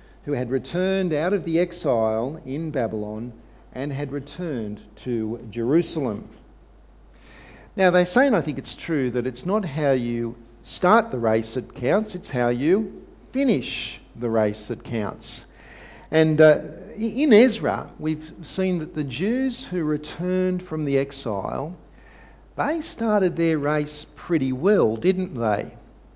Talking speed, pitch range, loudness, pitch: 140 wpm, 125-185 Hz, -23 LUFS, 150 Hz